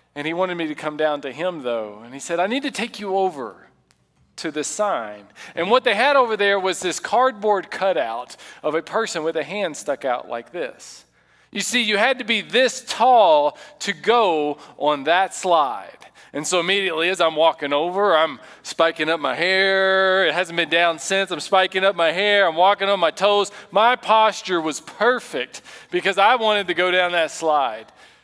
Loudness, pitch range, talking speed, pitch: -20 LUFS, 160-210 Hz, 200 wpm, 190 Hz